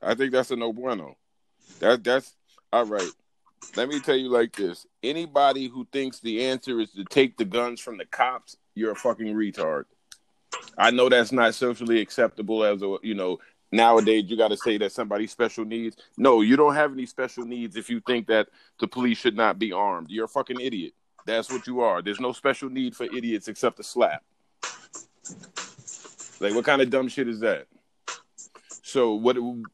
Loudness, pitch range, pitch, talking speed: -25 LUFS, 110-130 Hz, 120 Hz, 195 wpm